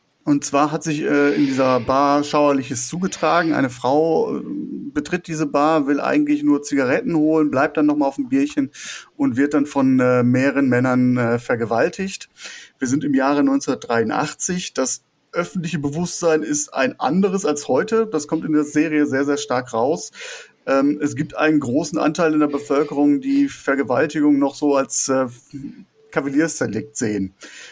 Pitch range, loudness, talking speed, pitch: 135-160 Hz, -19 LUFS, 160 wpm, 145 Hz